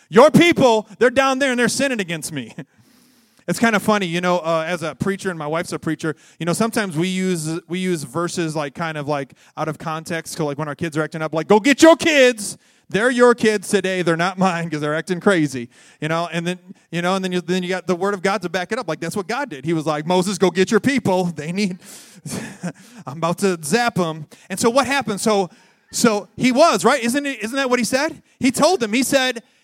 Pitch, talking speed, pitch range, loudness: 185 Hz, 255 wpm, 165-230 Hz, -19 LUFS